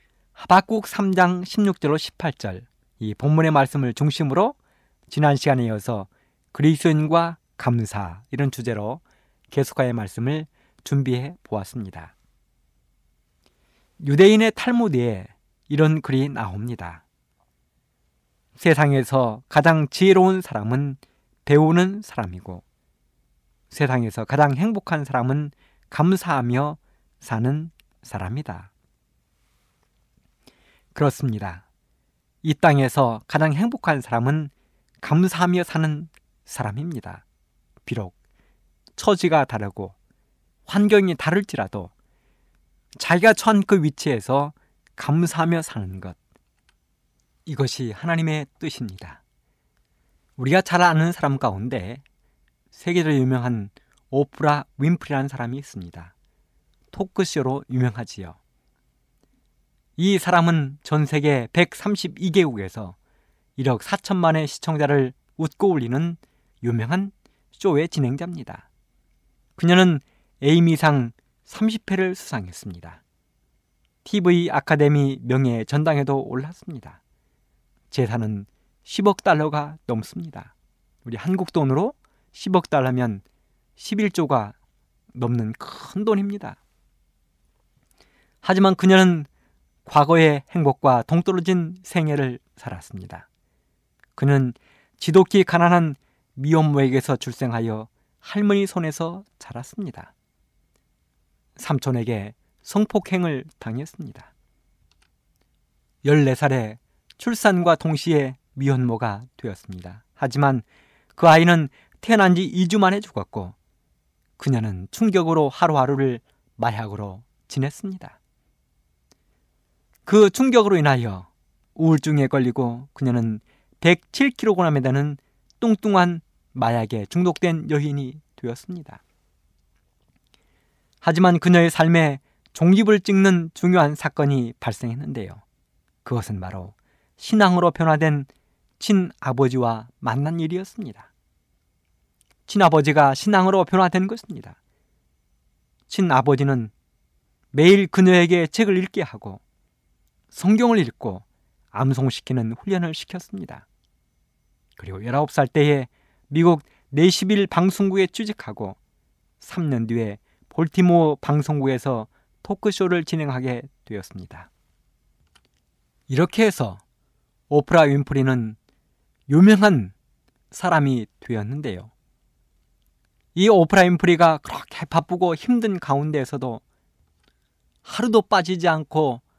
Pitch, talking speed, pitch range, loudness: 140 Hz, 230 characters per minute, 110-170 Hz, -20 LUFS